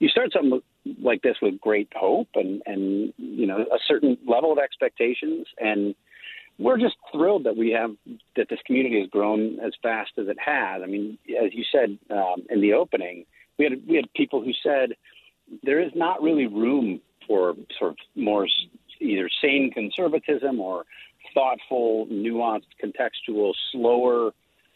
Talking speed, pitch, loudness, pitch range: 160 wpm, 120 Hz, -24 LUFS, 105-155 Hz